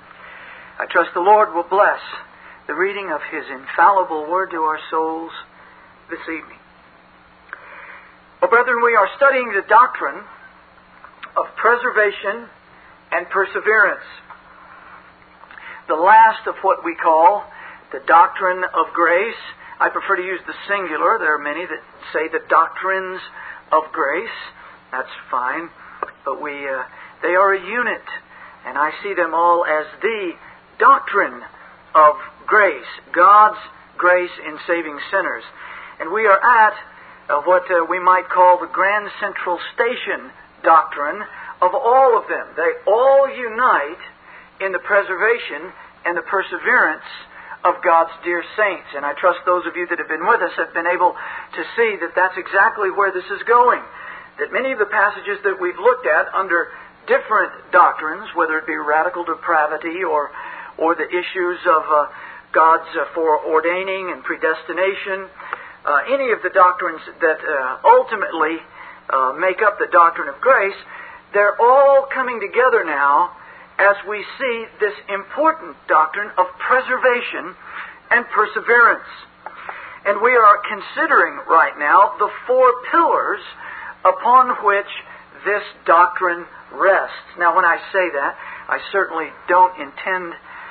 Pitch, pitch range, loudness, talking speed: 190 Hz, 170-240 Hz, -17 LUFS, 140 wpm